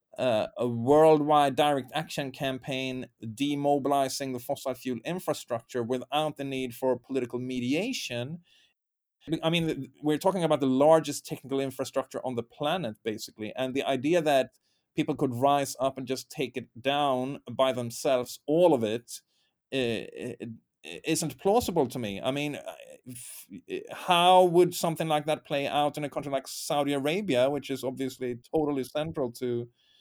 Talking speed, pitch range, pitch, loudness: 145 wpm, 125-150 Hz, 135 Hz, -28 LUFS